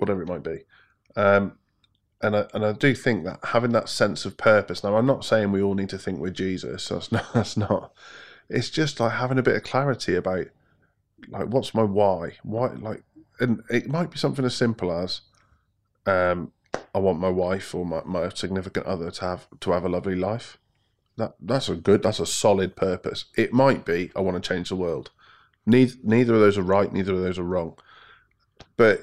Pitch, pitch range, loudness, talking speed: 100 Hz, 95-115 Hz, -24 LUFS, 210 wpm